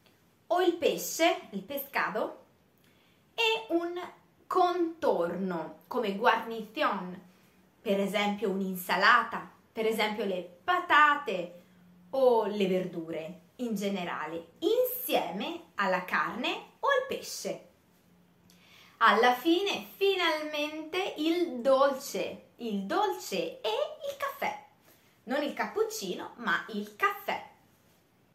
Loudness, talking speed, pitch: -30 LUFS, 95 wpm, 255 Hz